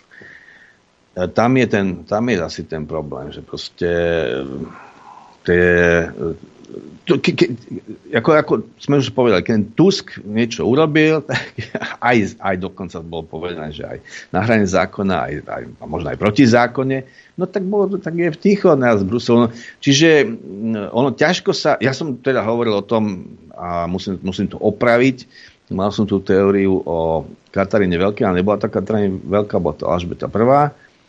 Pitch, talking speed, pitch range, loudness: 110 Hz, 150 wpm, 95-135 Hz, -17 LUFS